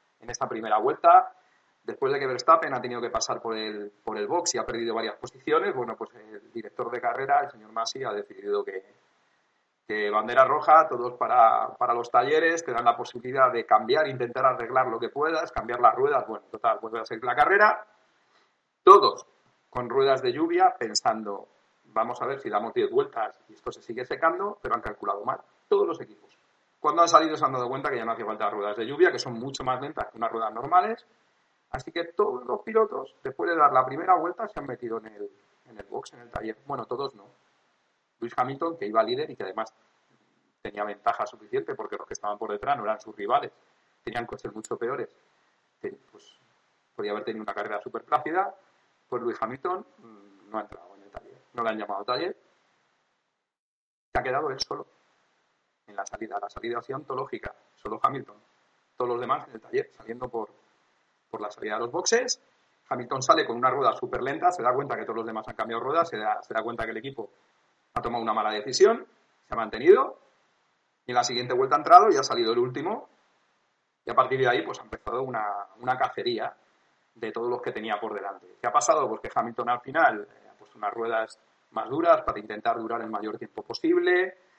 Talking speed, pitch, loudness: 215 wpm, 185 Hz, -26 LUFS